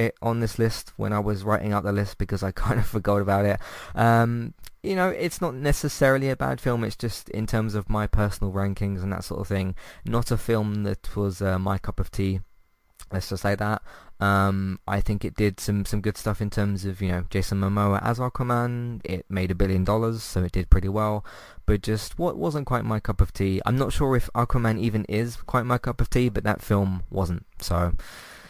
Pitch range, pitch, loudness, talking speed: 95-115 Hz, 105 Hz, -26 LUFS, 225 wpm